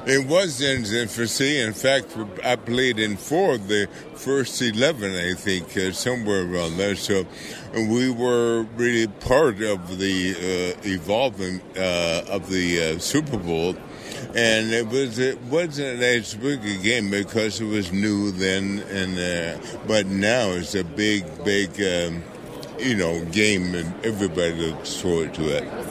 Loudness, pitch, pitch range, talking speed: -23 LUFS, 105 Hz, 95-120 Hz, 155 wpm